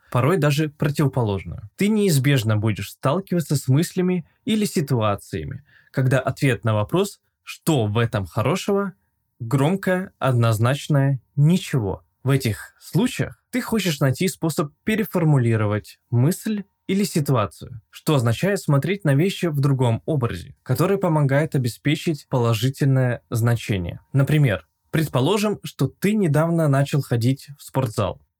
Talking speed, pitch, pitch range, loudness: 115 wpm, 140 Hz, 120-175 Hz, -22 LUFS